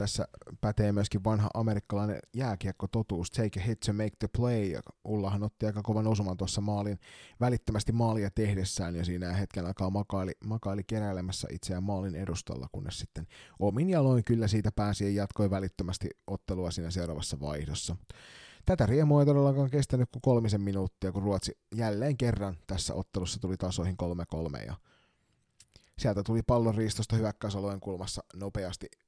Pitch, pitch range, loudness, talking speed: 100 Hz, 95-110 Hz, -32 LUFS, 155 wpm